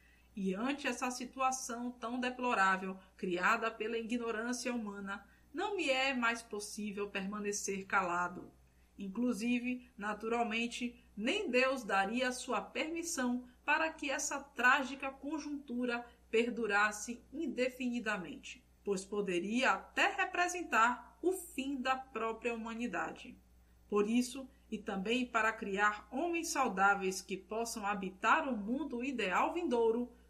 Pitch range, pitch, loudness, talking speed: 210-260 Hz, 235 Hz, -35 LUFS, 110 wpm